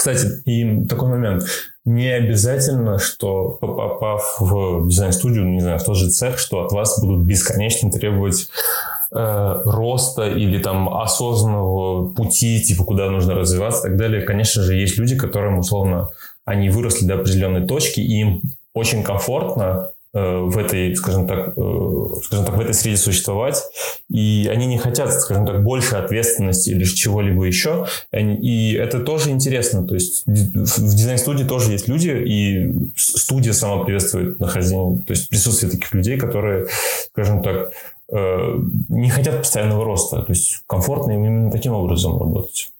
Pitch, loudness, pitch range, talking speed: 105 Hz, -18 LUFS, 95-115 Hz, 150 wpm